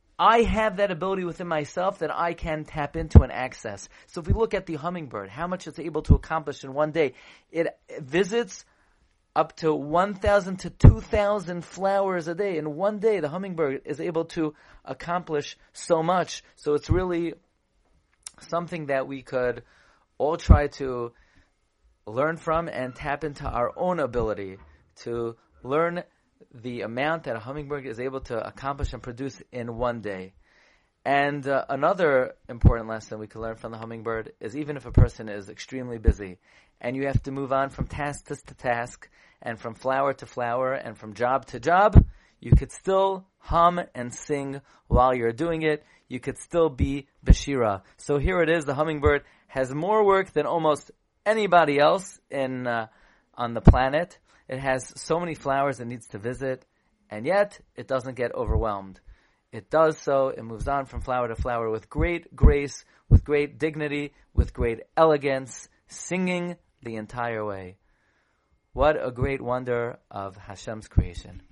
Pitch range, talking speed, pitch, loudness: 120-165 Hz, 170 wpm, 140 Hz, -26 LUFS